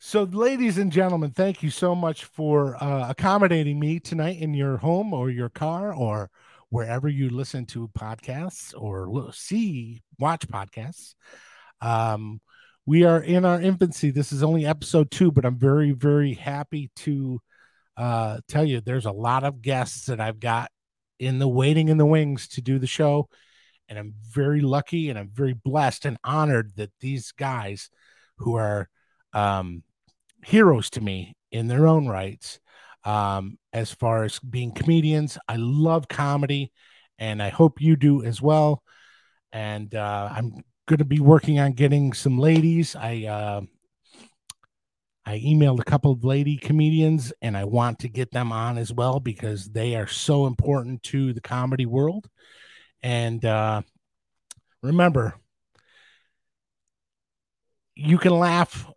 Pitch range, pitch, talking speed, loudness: 115-155 Hz, 135 Hz, 150 wpm, -23 LUFS